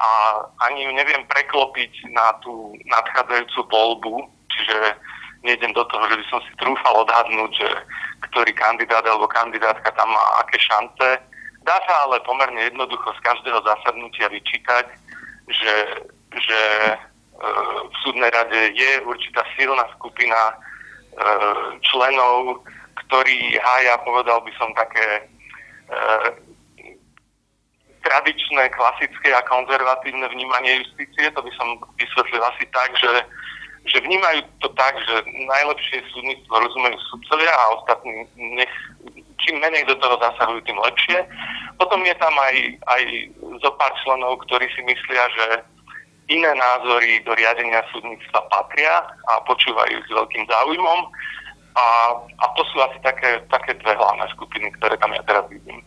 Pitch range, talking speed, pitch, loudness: 115-130 Hz, 135 wpm, 120 Hz, -18 LUFS